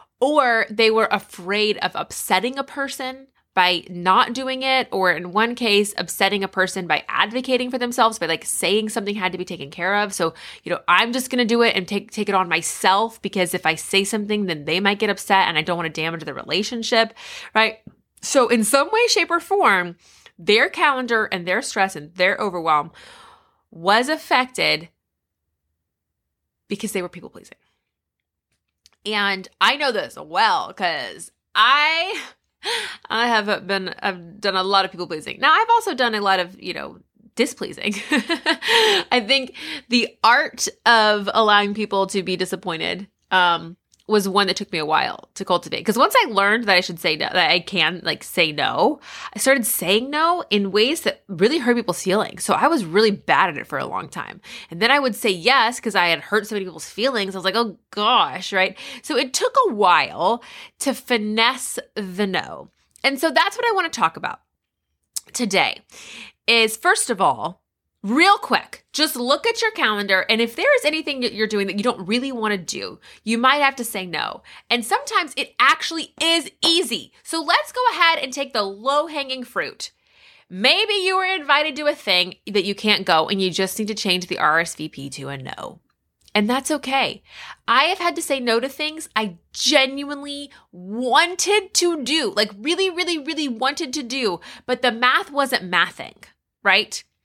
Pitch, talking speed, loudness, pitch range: 220 Hz, 190 wpm, -19 LUFS, 190-275 Hz